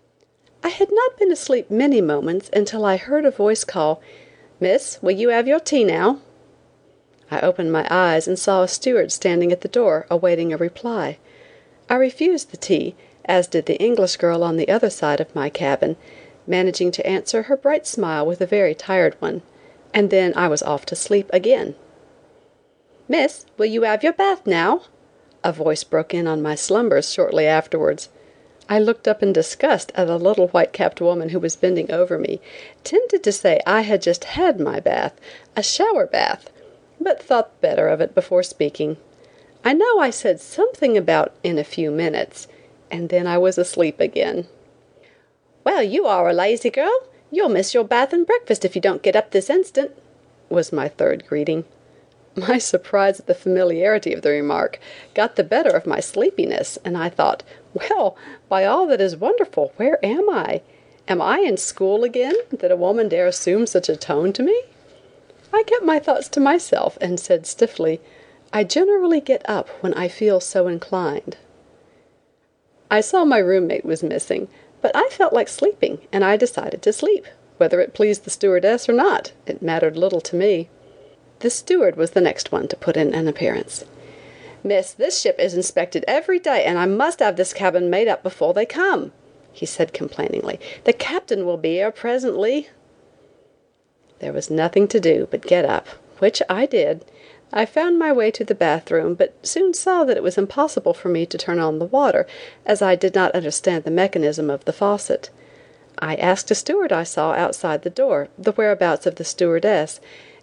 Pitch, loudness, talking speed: 210 Hz, -19 LUFS, 185 wpm